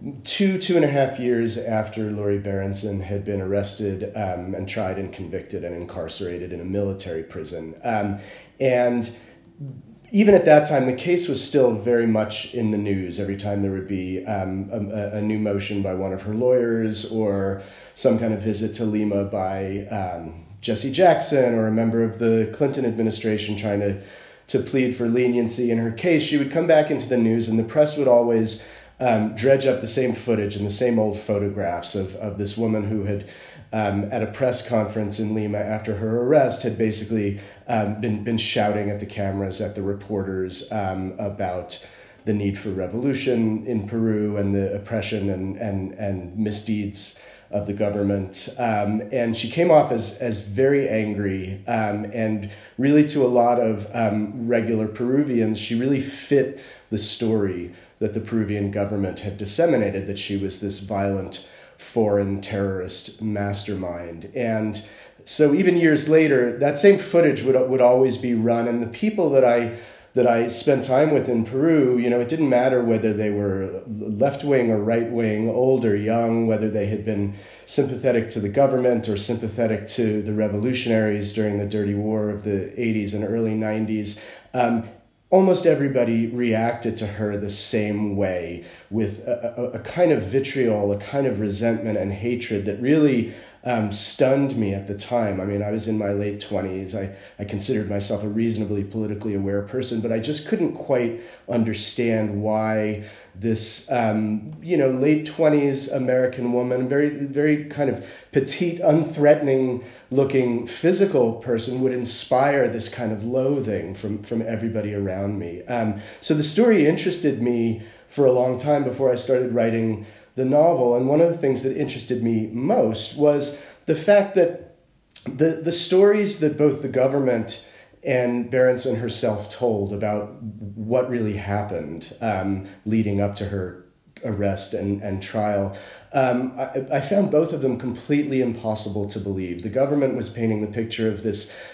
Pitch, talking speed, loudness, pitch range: 110 Hz, 170 wpm, -22 LUFS, 100-125 Hz